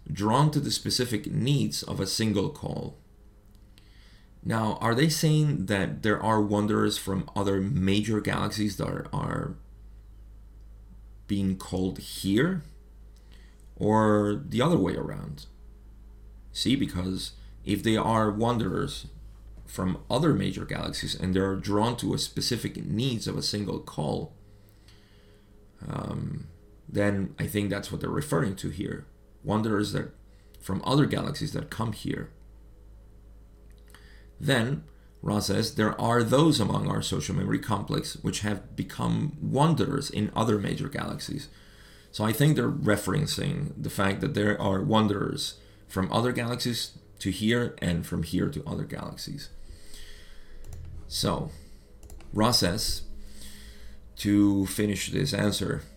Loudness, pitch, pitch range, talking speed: -28 LUFS, 105 Hz, 95-110 Hz, 130 wpm